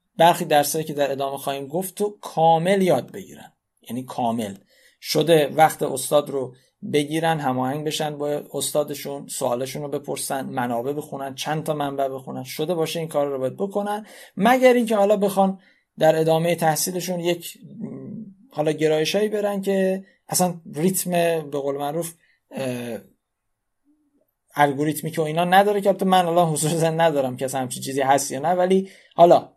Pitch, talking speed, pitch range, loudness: 160 Hz, 145 wpm, 145-190 Hz, -22 LUFS